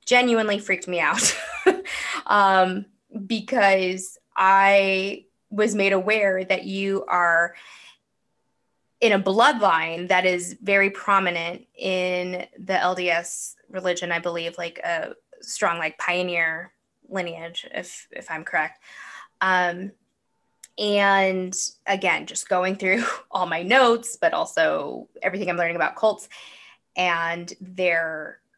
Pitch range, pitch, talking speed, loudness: 180-205 Hz, 190 Hz, 115 wpm, -22 LUFS